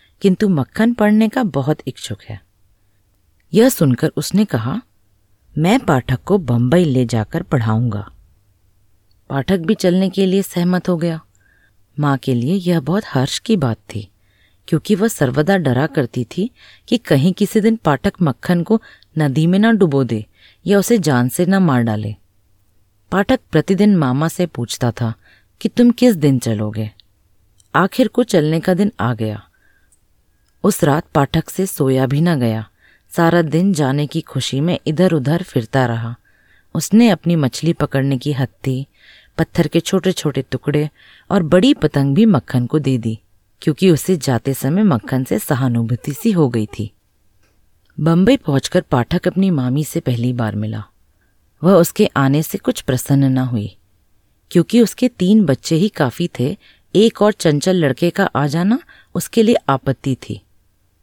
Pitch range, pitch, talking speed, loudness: 115-185 Hz, 145 Hz, 160 wpm, -16 LUFS